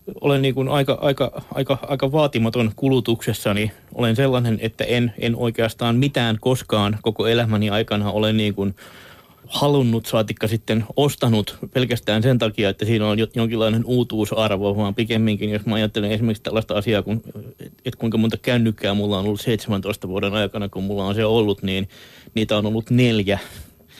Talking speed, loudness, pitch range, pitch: 160 wpm, -21 LUFS, 105-120 Hz, 110 Hz